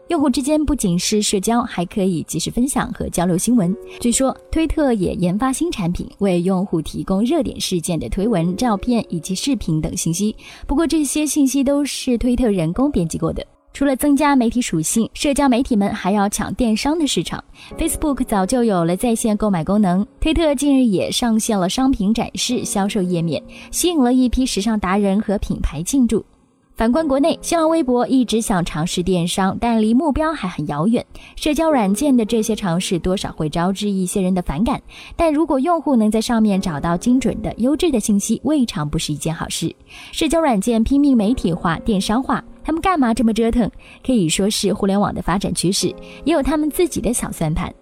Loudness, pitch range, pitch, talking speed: -18 LUFS, 190-270 Hz, 225 Hz, 310 characters per minute